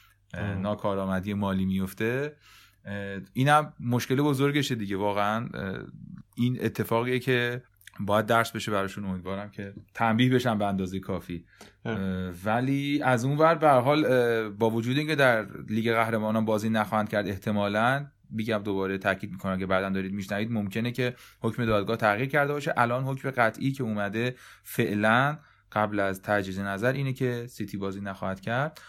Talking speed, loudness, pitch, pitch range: 145 wpm, -27 LUFS, 110 Hz, 100-125 Hz